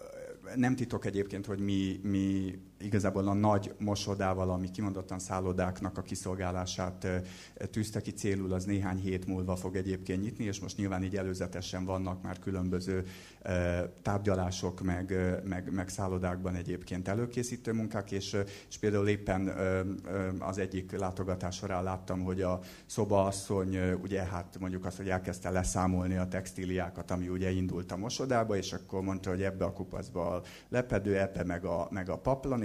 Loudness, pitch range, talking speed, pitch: -34 LUFS, 90-100 Hz, 155 wpm, 95 Hz